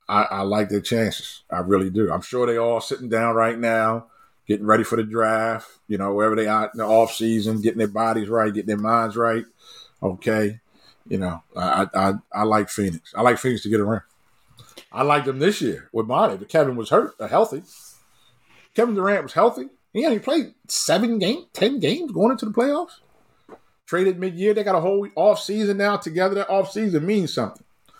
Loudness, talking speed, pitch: -22 LUFS, 205 wpm, 115 Hz